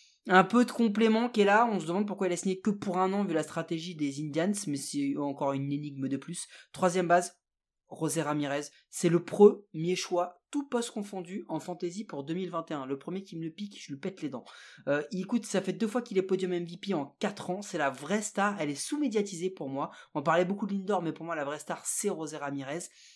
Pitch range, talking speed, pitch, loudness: 155-200 Hz, 240 wpm, 180 Hz, -31 LUFS